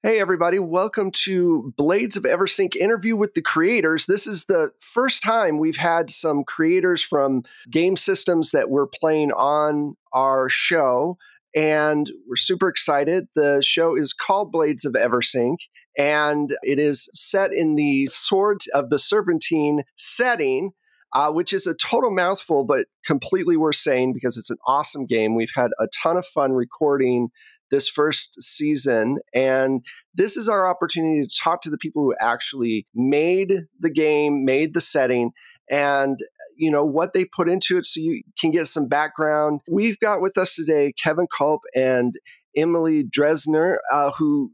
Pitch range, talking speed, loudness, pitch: 140-190 Hz, 160 wpm, -20 LUFS, 155 Hz